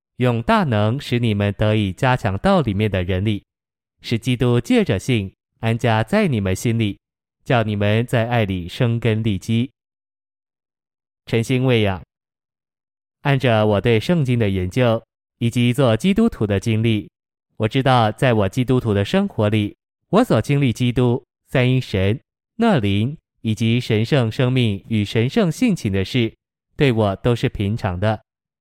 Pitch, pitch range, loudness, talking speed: 115 Hz, 105-125 Hz, -19 LUFS, 220 characters per minute